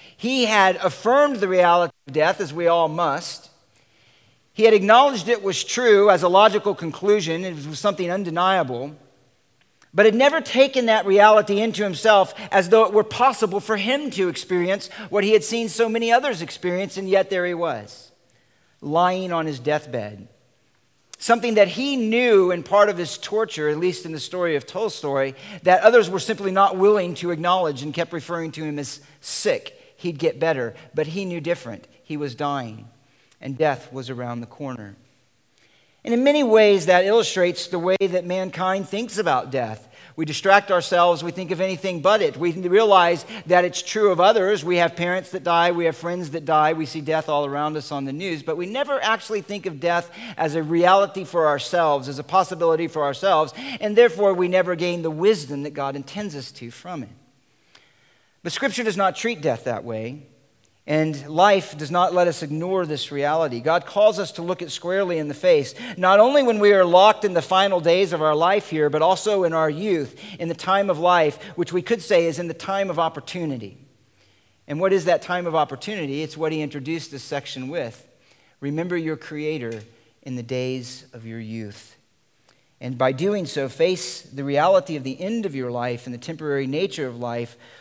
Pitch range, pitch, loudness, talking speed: 145-195 Hz, 170 Hz, -20 LUFS, 195 wpm